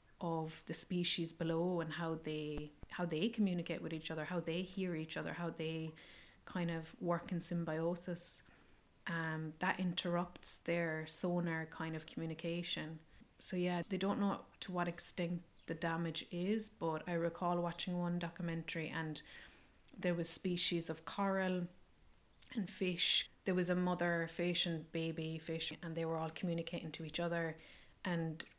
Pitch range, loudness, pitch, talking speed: 160-175 Hz, -39 LUFS, 170 Hz, 155 wpm